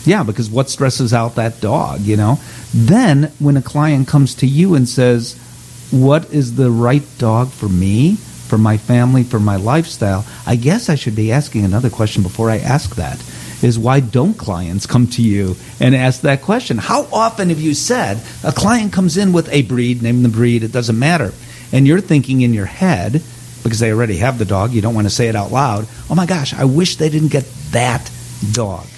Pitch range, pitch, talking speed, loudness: 115-145 Hz, 125 Hz, 210 wpm, -14 LUFS